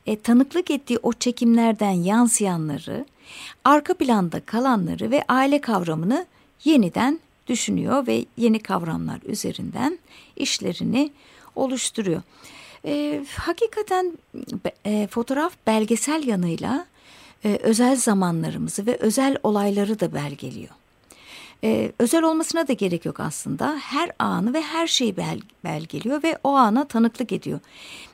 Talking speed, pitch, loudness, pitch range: 115 wpm, 235 Hz, -22 LUFS, 205-285 Hz